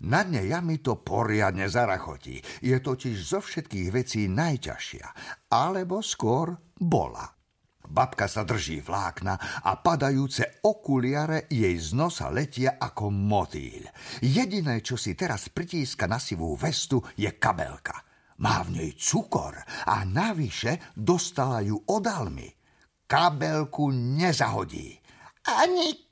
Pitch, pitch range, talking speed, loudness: 130 Hz, 105-160 Hz, 115 wpm, -27 LUFS